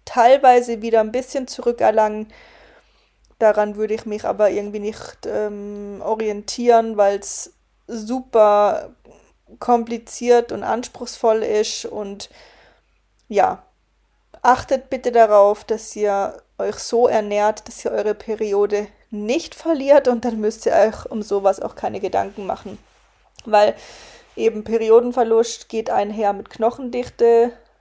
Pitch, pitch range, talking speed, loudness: 225 Hz, 210-240 Hz, 120 wpm, -19 LUFS